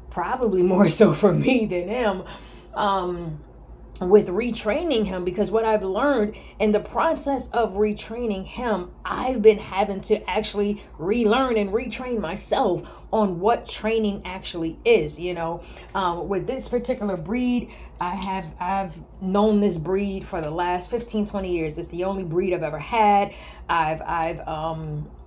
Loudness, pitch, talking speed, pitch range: -23 LUFS, 200 Hz, 150 wpm, 180-220 Hz